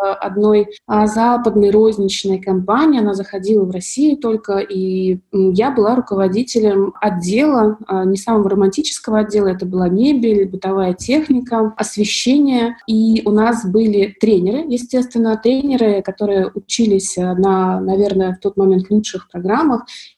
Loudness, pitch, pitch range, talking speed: -15 LUFS, 210 Hz, 195-230 Hz, 120 wpm